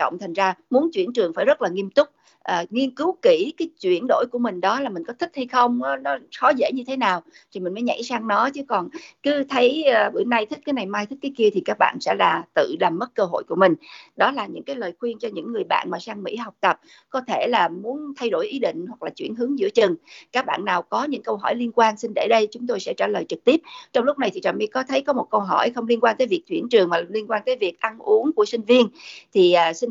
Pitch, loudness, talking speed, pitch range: 250 Hz, -22 LUFS, 295 wpm, 220-310 Hz